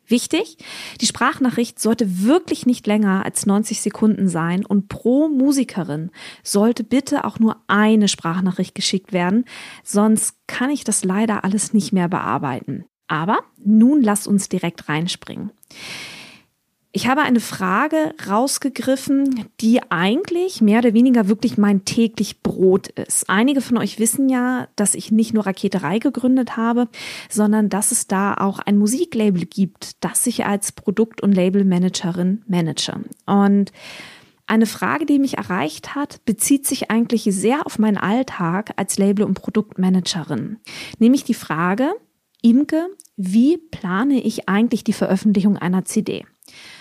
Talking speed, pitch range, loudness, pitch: 140 wpm, 195-245 Hz, -19 LUFS, 215 Hz